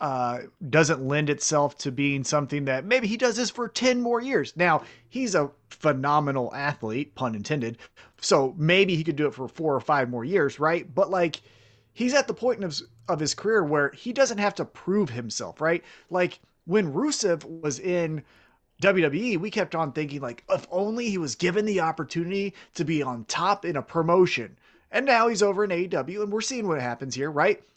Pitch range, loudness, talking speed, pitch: 140-200 Hz, -25 LUFS, 200 wpm, 165 Hz